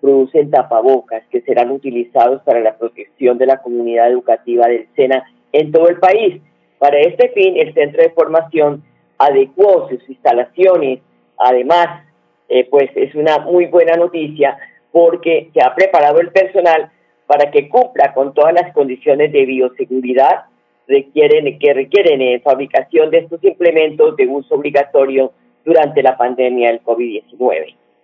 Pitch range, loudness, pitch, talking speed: 125-185 Hz, -13 LUFS, 145 Hz, 145 wpm